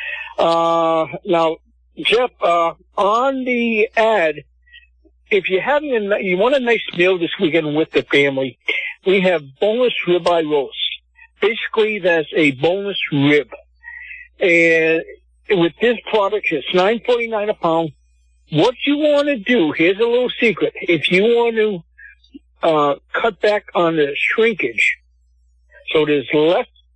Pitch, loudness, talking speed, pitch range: 185 Hz, -17 LUFS, 135 wpm, 160-235 Hz